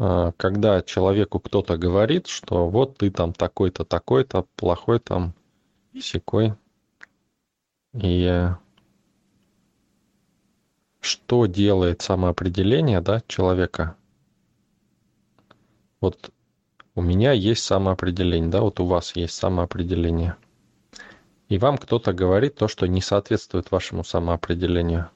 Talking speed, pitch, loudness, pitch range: 95 wpm, 95 Hz, -22 LUFS, 90-105 Hz